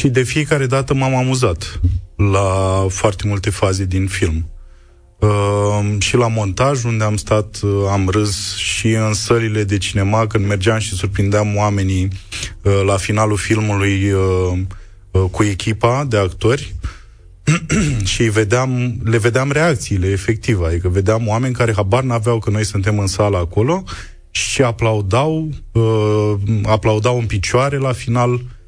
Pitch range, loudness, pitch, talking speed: 95-115 Hz, -16 LUFS, 105 Hz, 140 wpm